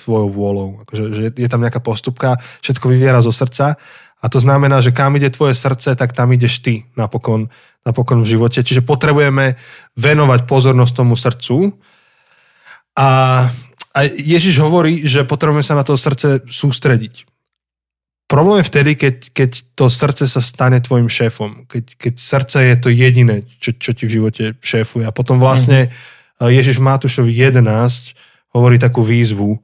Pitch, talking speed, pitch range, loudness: 125 Hz, 155 wpm, 120-135 Hz, -13 LUFS